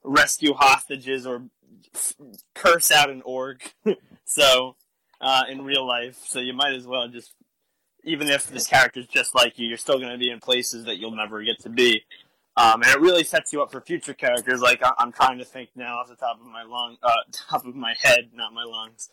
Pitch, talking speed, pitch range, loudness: 125 Hz, 220 wpm, 120-140 Hz, -21 LUFS